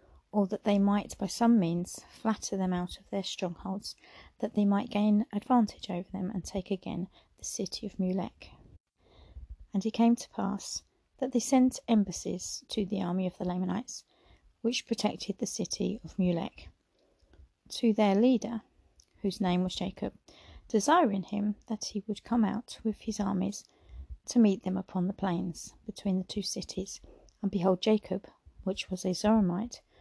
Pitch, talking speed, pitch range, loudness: 200 Hz, 165 wpm, 185-220 Hz, -31 LUFS